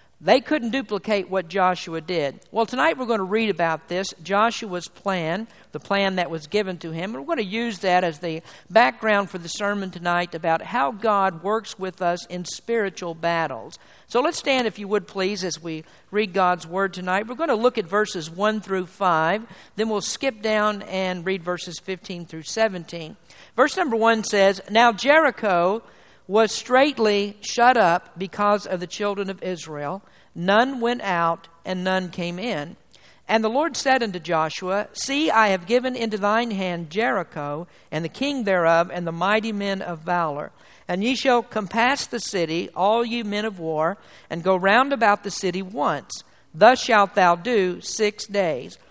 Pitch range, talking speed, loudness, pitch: 175-220 Hz, 180 wpm, -22 LUFS, 195 Hz